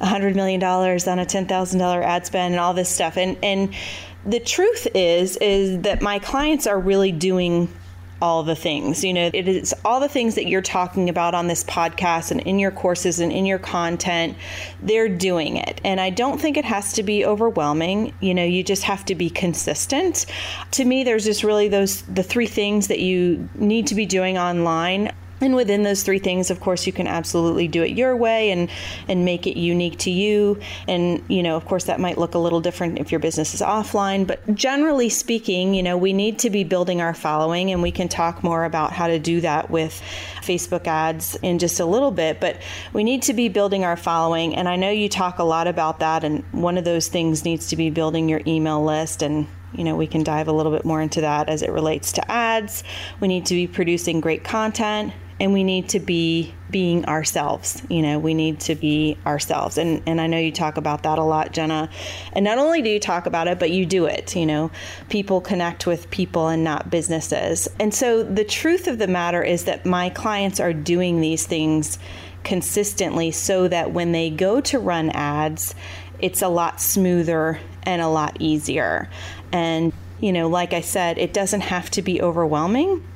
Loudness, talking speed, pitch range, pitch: -21 LUFS, 215 wpm, 160-195 Hz, 175 Hz